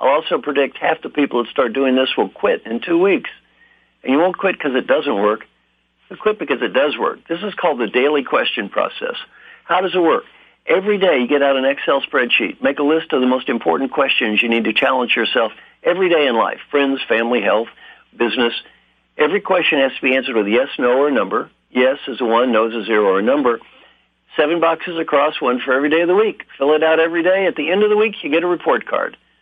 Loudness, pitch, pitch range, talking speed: -17 LUFS, 140 Hz, 125-175 Hz, 240 wpm